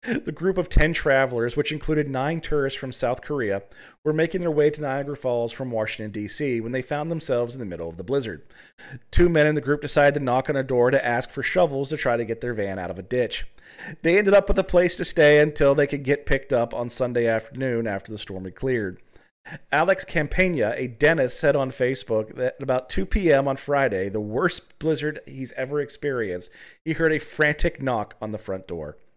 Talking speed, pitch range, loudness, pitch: 220 wpm, 120-150 Hz, -23 LUFS, 135 Hz